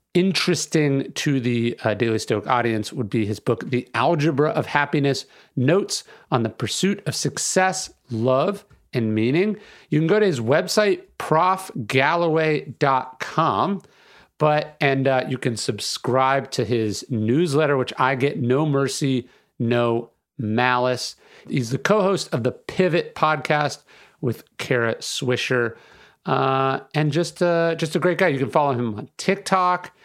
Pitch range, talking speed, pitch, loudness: 125-170 Hz, 145 wpm, 140 Hz, -22 LUFS